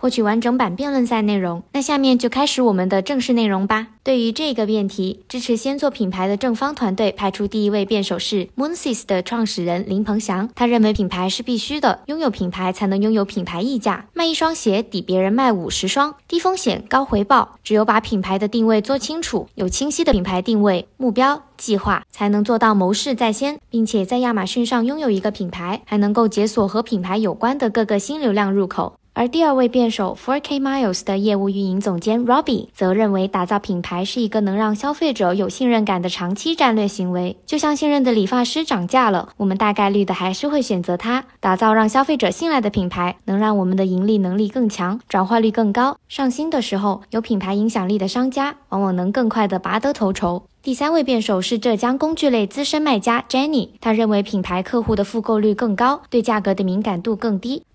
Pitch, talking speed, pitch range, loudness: 220 Hz, 345 characters per minute, 195-255 Hz, -19 LUFS